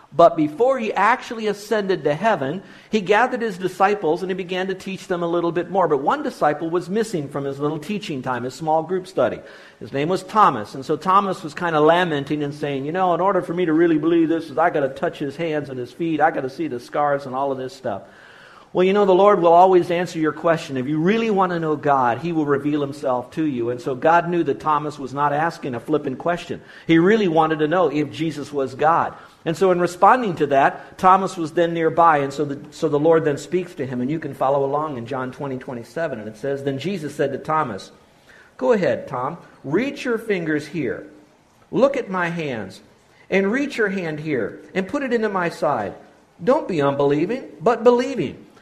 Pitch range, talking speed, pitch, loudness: 145-185 Hz, 230 wpm, 165 Hz, -20 LUFS